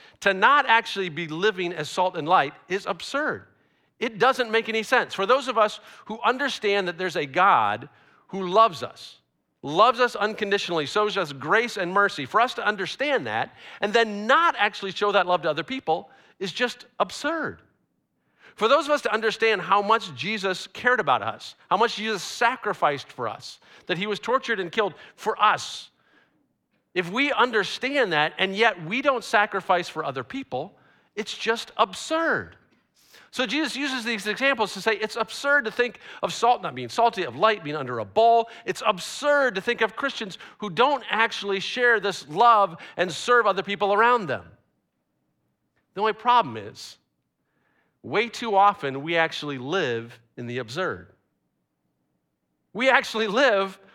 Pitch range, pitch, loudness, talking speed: 185-235 Hz, 210 Hz, -23 LUFS, 170 wpm